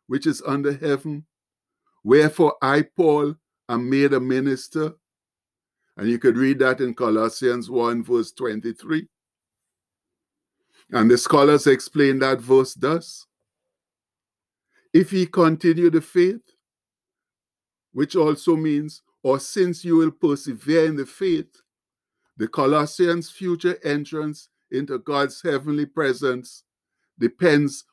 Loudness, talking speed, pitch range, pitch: -21 LUFS, 115 wpm, 130-165 Hz, 145 Hz